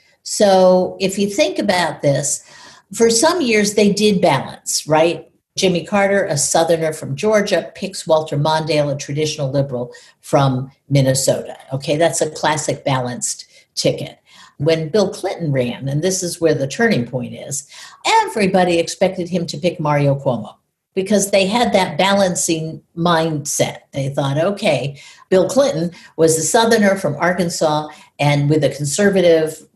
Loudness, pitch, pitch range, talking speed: -17 LUFS, 165 Hz, 145-195 Hz, 145 wpm